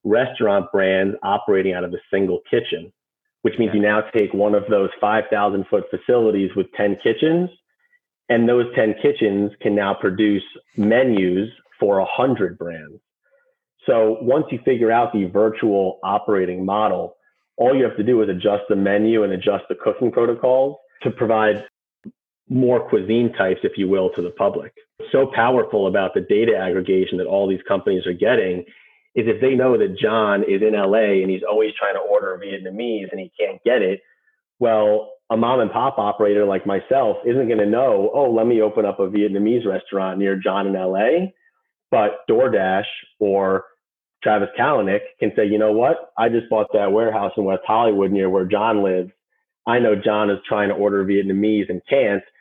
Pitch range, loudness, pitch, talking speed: 100-160 Hz, -19 LUFS, 105 Hz, 180 wpm